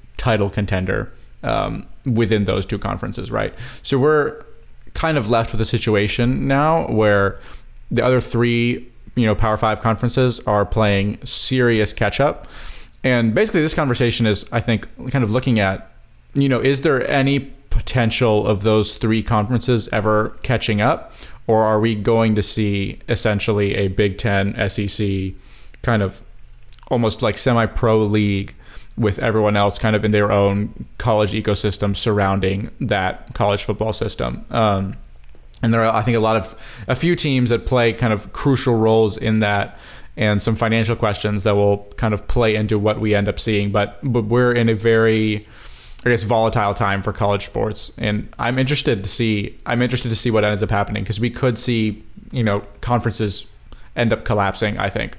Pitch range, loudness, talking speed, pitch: 105-120 Hz, -19 LUFS, 175 wpm, 110 Hz